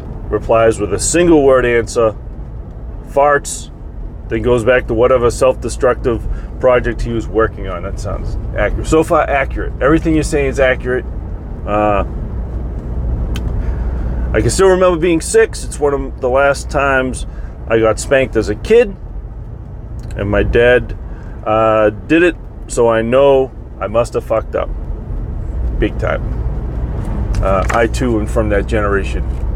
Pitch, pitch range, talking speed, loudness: 110 Hz, 100-130 Hz, 145 wpm, -15 LUFS